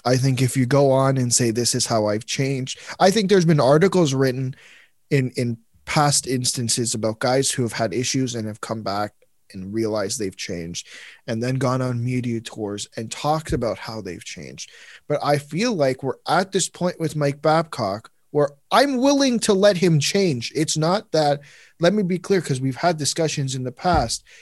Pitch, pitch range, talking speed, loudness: 135 Hz, 120-165 Hz, 200 wpm, -21 LUFS